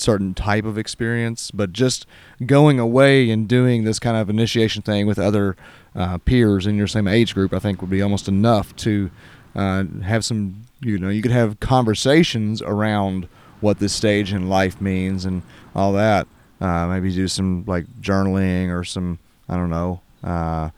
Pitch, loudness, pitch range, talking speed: 100 Hz, -20 LUFS, 95-110 Hz, 180 wpm